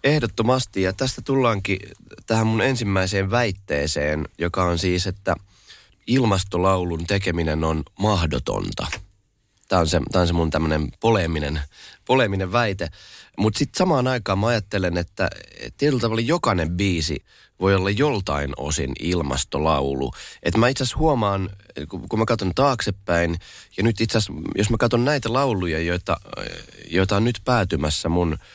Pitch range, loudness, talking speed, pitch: 85-115 Hz, -22 LUFS, 135 wpm, 95 Hz